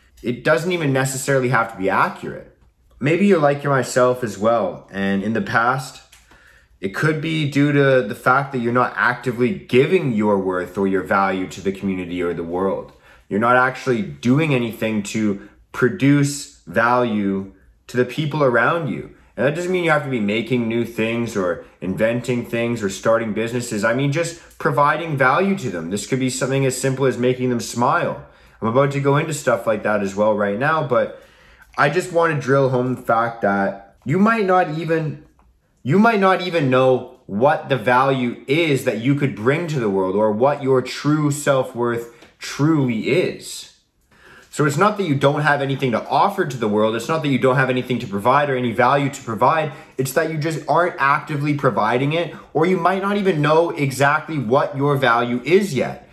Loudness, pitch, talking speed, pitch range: -19 LUFS, 130 Hz, 195 wpm, 115-150 Hz